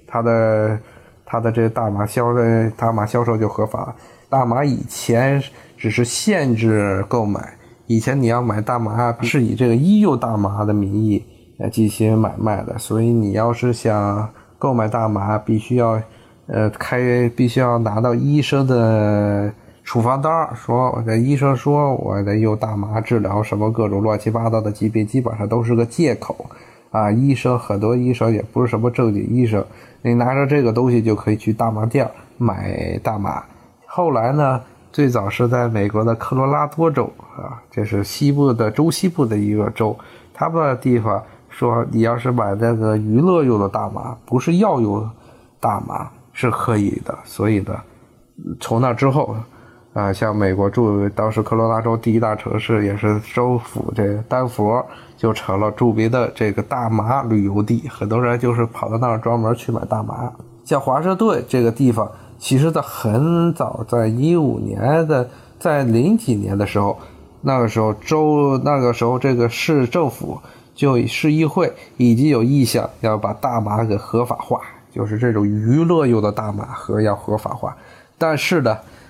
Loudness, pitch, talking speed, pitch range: -18 LUFS, 115 Hz, 250 characters per minute, 110-125 Hz